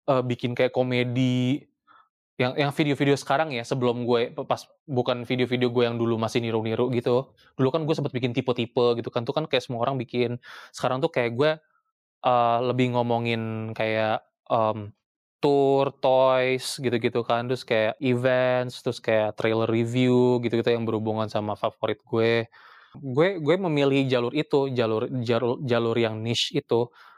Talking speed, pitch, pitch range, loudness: 155 wpm, 125 Hz, 115-130 Hz, -25 LUFS